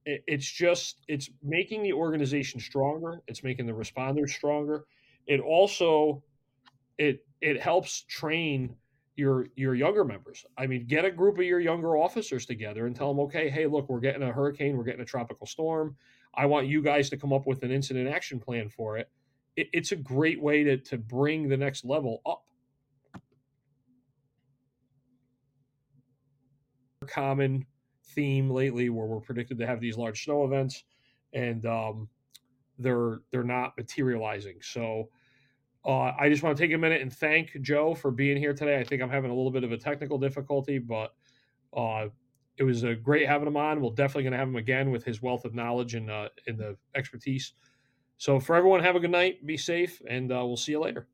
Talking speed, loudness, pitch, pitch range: 185 wpm, -29 LUFS, 135 Hz, 125-145 Hz